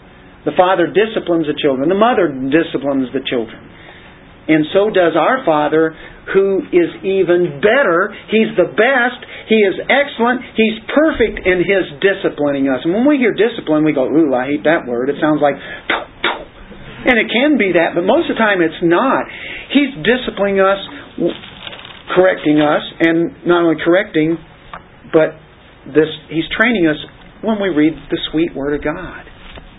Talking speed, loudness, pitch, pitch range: 160 wpm, -15 LUFS, 170 Hz, 155-215 Hz